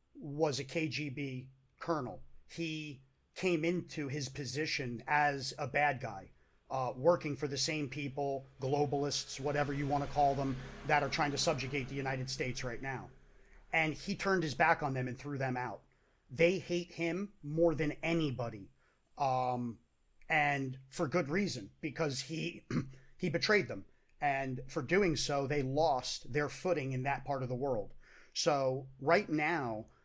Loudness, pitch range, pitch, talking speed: -35 LUFS, 130-160 Hz, 145 Hz, 160 wpm